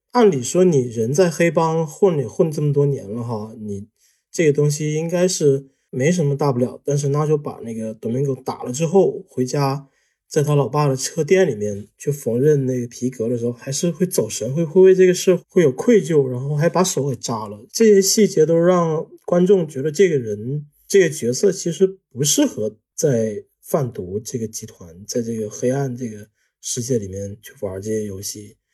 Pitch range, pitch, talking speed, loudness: 115-170 Hz, 140 Hz, 280 characters per minute, -19 LUFS